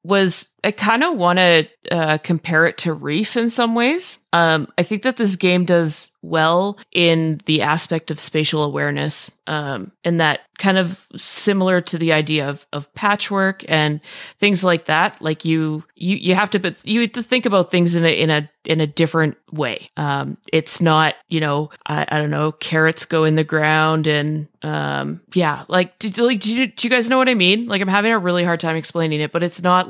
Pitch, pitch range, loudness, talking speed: 170 Hz, 155-195 Hz, -17 LUFS, 215 wpm